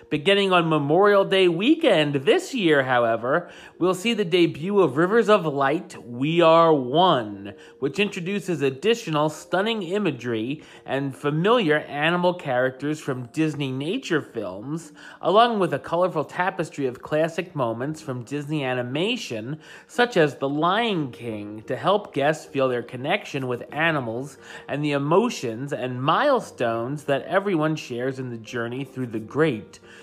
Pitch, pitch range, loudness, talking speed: 155 Hz, 130-180 Hz, -23 LUFS, 140 wpm